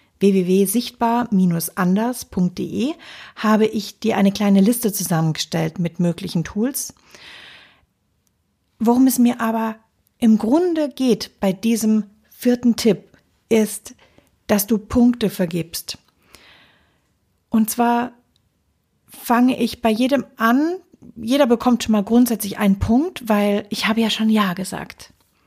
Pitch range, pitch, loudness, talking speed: 200-240 Hz, 220 Hz, -19 LUFS, 115 wpm